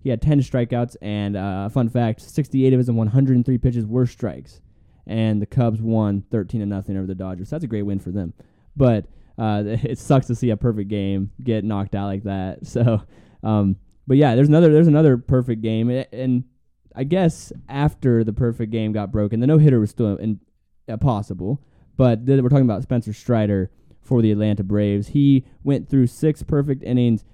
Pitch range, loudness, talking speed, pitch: 105-130 Hz, -20 LUFS, 200 wpm, 115 Hz